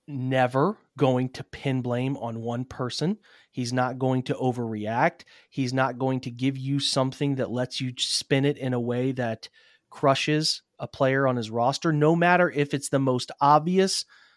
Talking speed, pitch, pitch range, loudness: 175 wpm, 130 Hz, 125-145 Hz, -25 LUFS